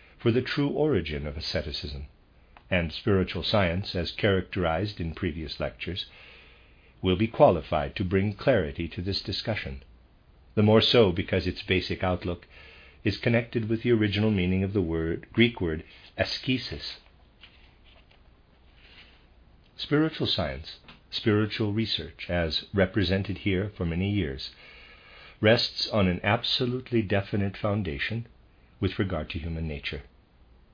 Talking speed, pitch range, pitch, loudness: 125 wpm, 80-110 Hz, 95 Hz, -27 LUFS